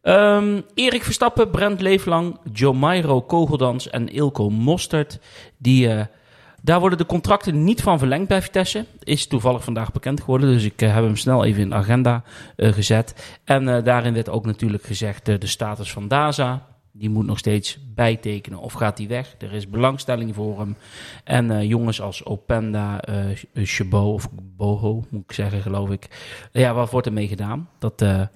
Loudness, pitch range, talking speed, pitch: -20 LUFS, 105-140 Hz, 185 wpm, 120 Hz